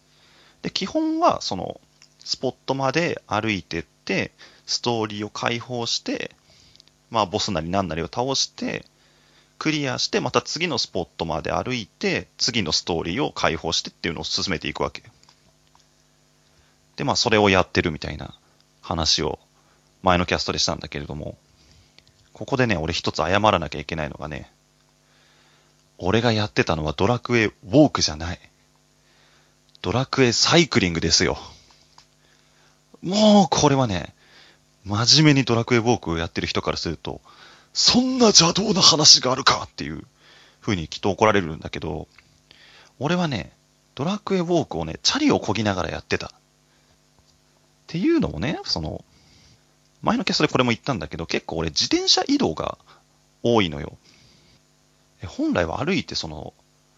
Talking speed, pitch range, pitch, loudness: 315 characters per minute, 85-135 Hz, 105 Hz, -21 LUFS